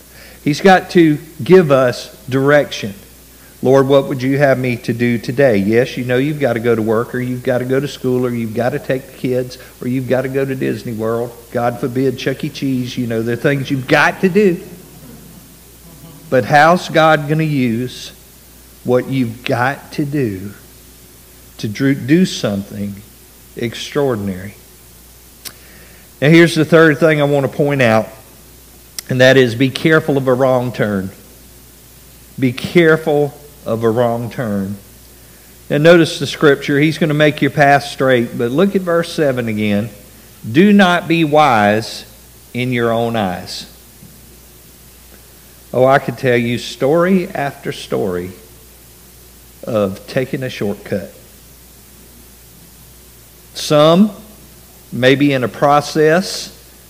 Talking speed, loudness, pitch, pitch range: 150 wpm, -14 LUFS, 130 Hz, 105-145 Hz